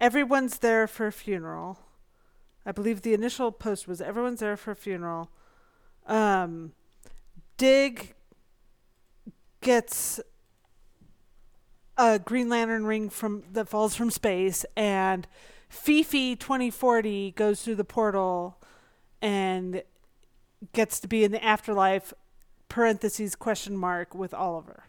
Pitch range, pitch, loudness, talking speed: 190-230 Hz, 215 Hz, -27 LUFS, 110 wpm